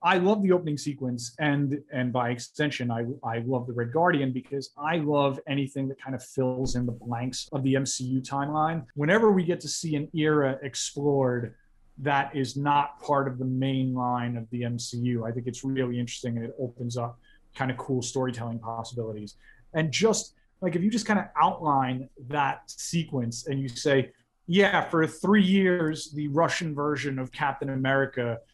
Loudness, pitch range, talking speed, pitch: -27 LUFS, 125-150 Hz, 185 wpm, 135 Hz